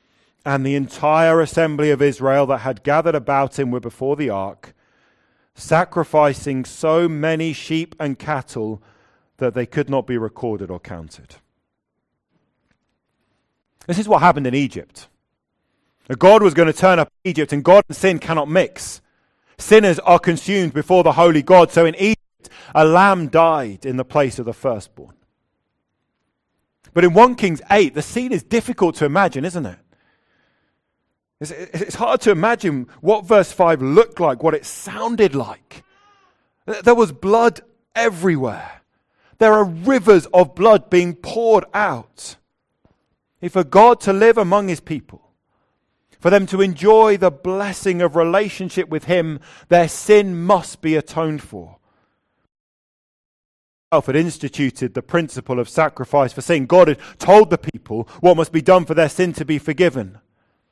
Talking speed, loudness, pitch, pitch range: 155 wpm, -16 LUFS, 160 Hz, 135-190 Hz